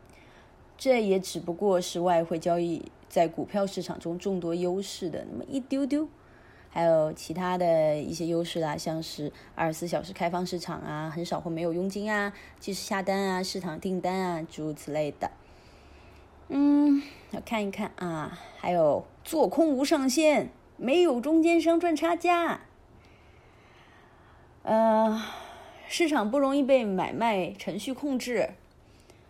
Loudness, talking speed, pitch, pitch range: -28 LUFS, 215 characters per minute, 190 Hz, 170-275 Hz